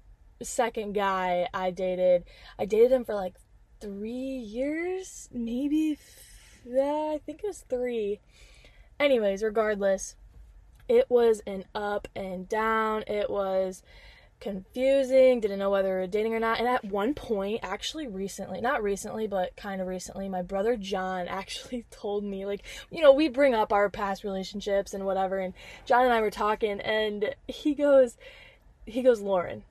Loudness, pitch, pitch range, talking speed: -28 LUFS, 215 Hz, 195-255 Hz, 160 wpm